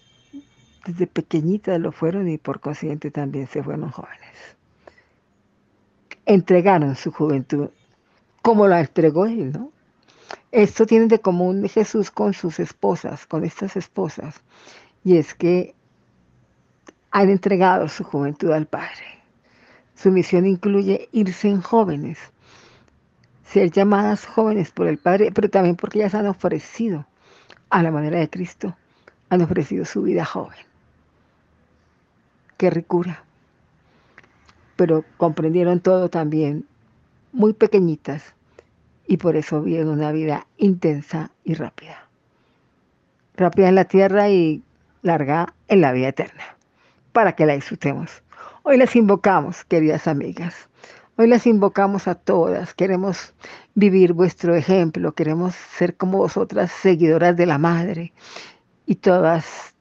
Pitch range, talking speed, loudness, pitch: 155-195 Hz, 120 wpm, -19 LUFS, 180 Hz